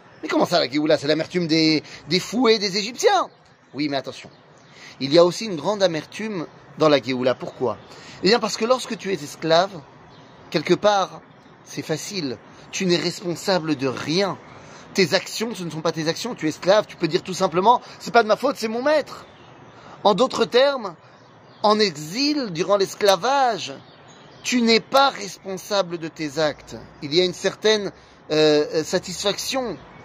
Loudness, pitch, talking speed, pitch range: -21 LUFS, 180 Hz, 175 wpm, 155-210 Hz